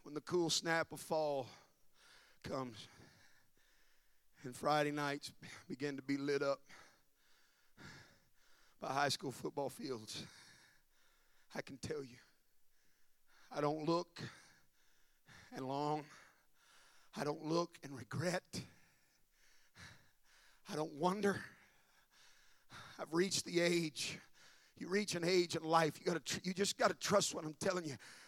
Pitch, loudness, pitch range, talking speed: 155 Hz, -40 LUFS, 145-175 Hz, 125 wpm